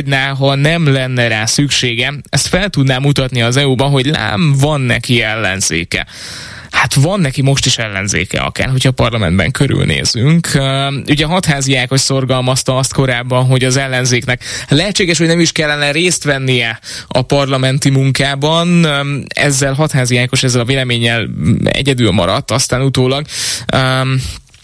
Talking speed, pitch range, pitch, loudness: 135 wpm, 125-140 Hz, 135 Hz, -12 LUFS